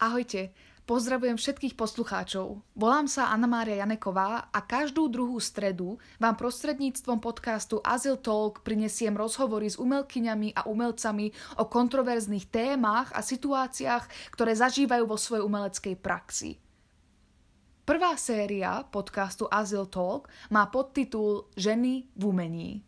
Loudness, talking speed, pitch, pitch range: -29 LUFS, 120 wpm, 220 Hz, 205-250 Hz